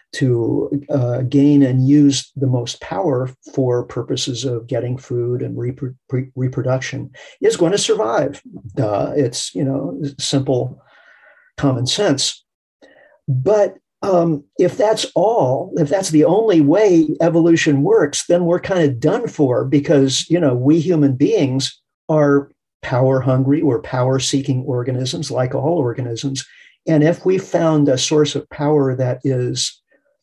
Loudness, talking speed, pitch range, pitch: -17 LUFS, 145 wpm, 130-160 Hz, 140 Hz